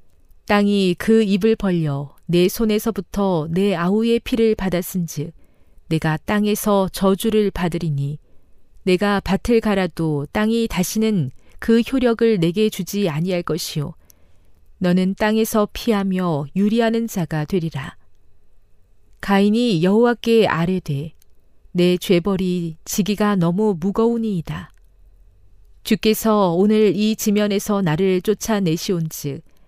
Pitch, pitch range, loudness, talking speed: 185 Hz, 155-210 Hz, -19 LUFS, 245 characters per minute